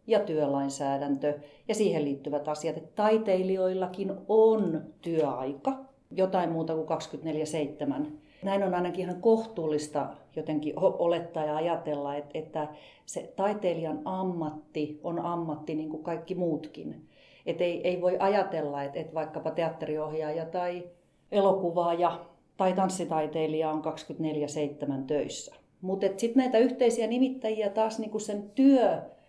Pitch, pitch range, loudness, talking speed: 170 Hz, 155-195 Hz, -30 LUFS, 115 wpm